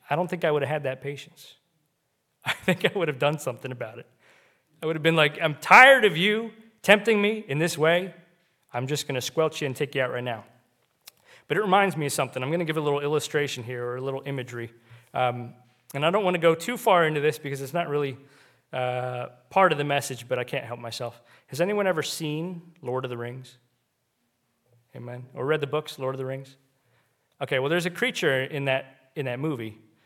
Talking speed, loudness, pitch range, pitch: 230 wpm, -24 LUFS, 125-165 Hz, 140 Hz